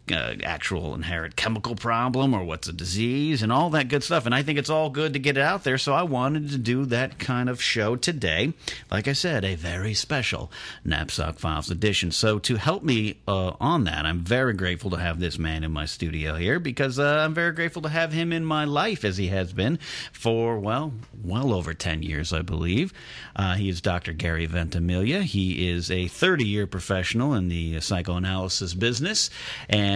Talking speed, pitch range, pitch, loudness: 205 wpm, 90-135 Hz, 105 Hz, -25 LUFS